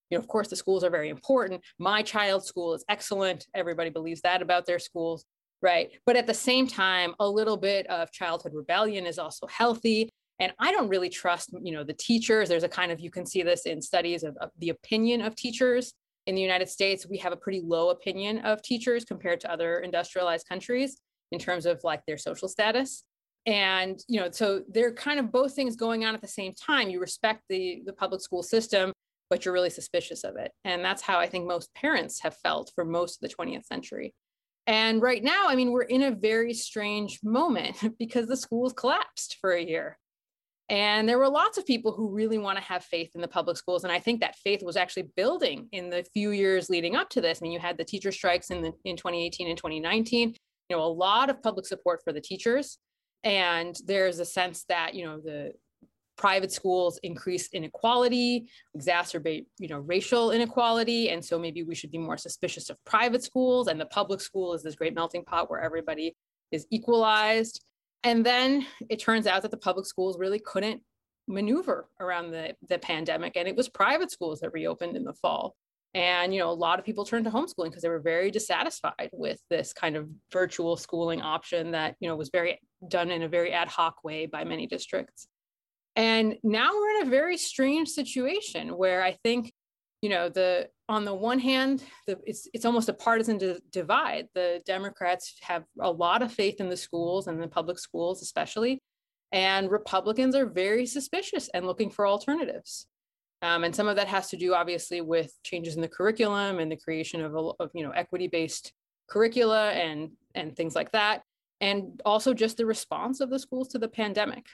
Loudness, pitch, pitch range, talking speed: -28 LUFS, 190 Hz, 175-230 Hz, 205 wpm